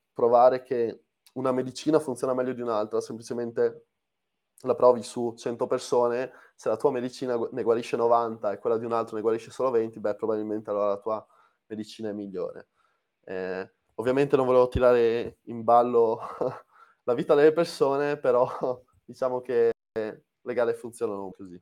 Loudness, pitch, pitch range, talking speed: -26 LUFS, 115 Hz, 110-125 Hz, 155 wpm